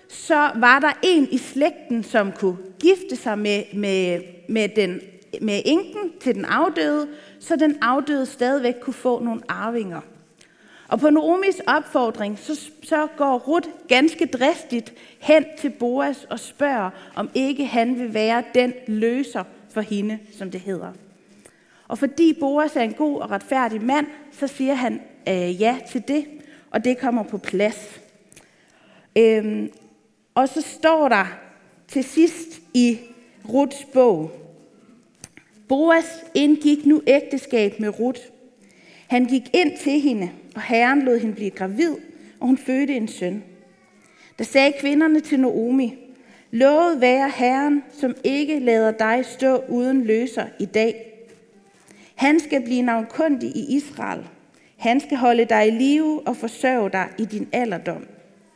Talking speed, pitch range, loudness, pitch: 145 wpm, 220-290 Hz, -21 LUFS, 250 Hz